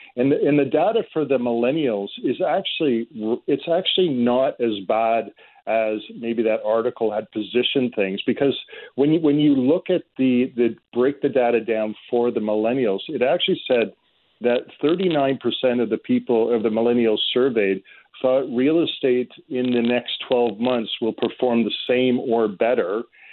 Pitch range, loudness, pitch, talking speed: 115-135 Hz, -21 LUFS, 120 Hz, 170 wpm